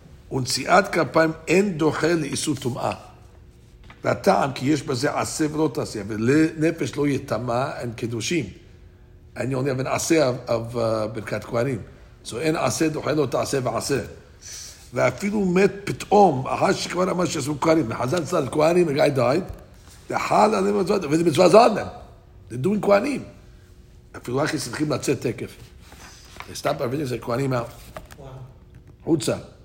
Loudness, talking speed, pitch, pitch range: -22 LUFS, 130 wpm, 140 Hz, 120-160 Hz